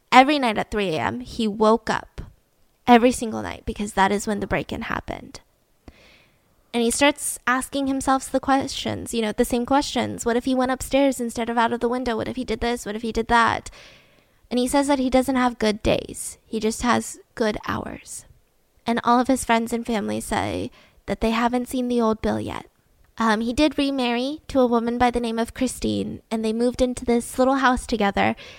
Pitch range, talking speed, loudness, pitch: 225-255 Hz, 210 wpm, -22 LUFS, 240 Hz